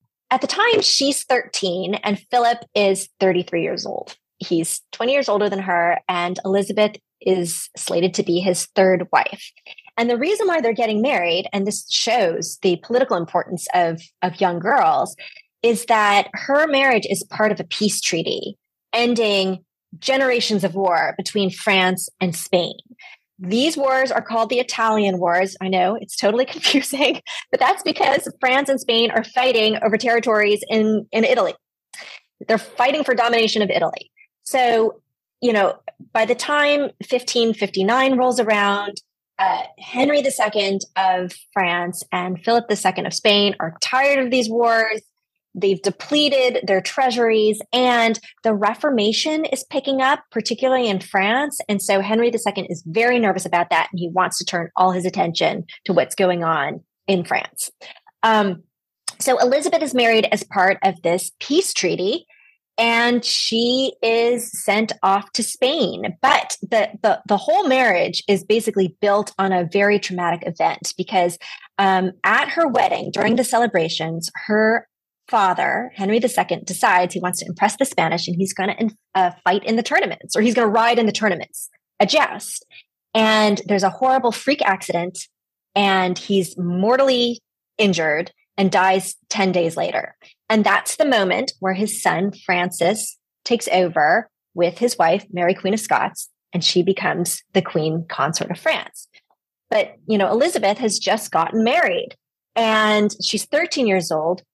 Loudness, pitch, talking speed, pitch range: -19 LUFS, 210 Hz, 160 wpm, 185-245 Hz